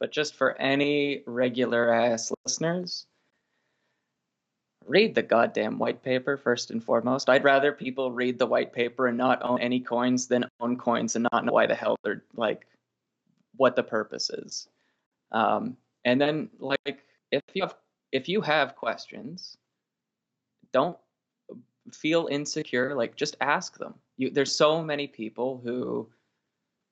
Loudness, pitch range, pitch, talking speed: -27 LUFS, 125-140 Hz, 130 Hz, 145 wpm